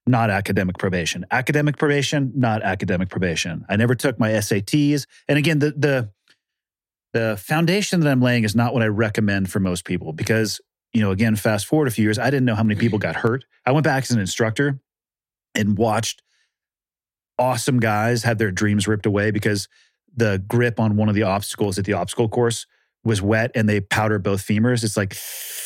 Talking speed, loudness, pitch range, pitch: 195 wpm, -20 LUFS, 105-125 Hz, 110 Hz